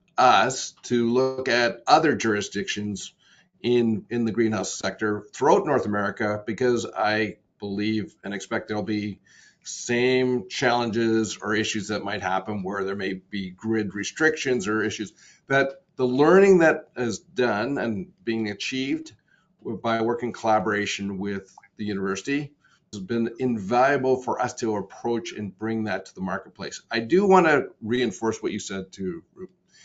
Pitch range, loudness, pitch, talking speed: 105-125 Hz, -24 LUFS, 110 Hz, 150 wpm